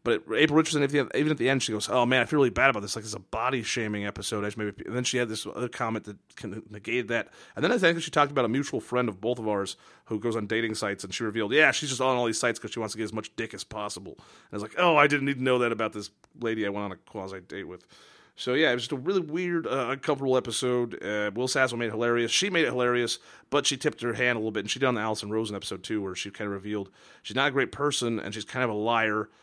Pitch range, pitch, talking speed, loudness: 105-130 Hz, 115 Hz, 305 wpm, -27 LUFS